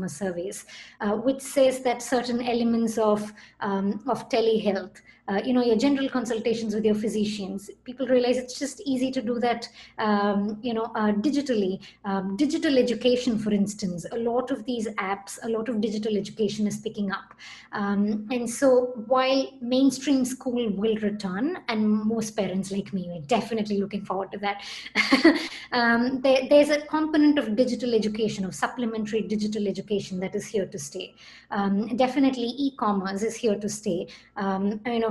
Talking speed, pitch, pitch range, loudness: 165 wpm, 225 Hz, 205-250 Hz, -26 LUFS